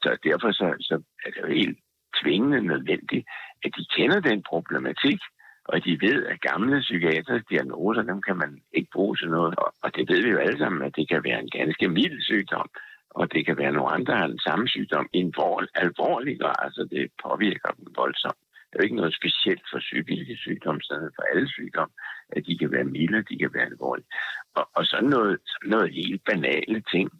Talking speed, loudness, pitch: 210 wpm, -25 LUFS, 110 Hz